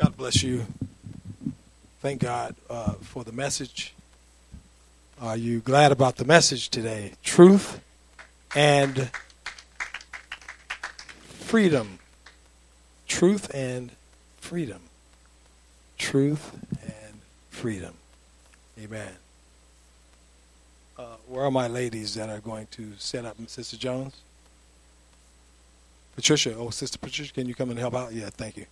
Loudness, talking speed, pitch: -25 LUFS, 110 wpm, 110 Hz